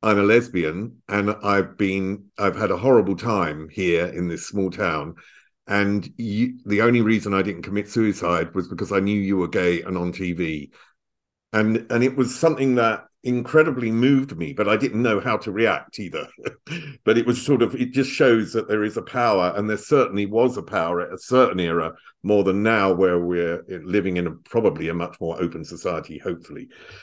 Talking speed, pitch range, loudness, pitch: 200 wpm, 90-115 Hz, -22 LUFS, 100 Hz